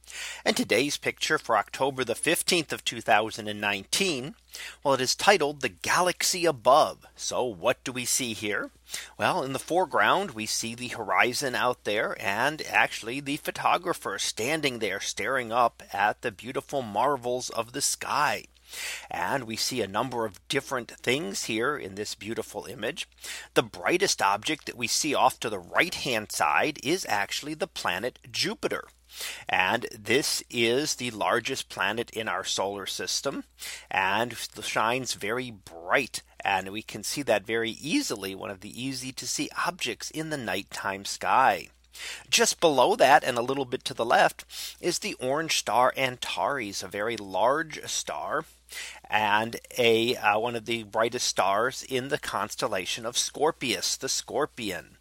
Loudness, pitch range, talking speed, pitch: -27 LUFS, 110-135 Hz, 155 wpm, 125 Hz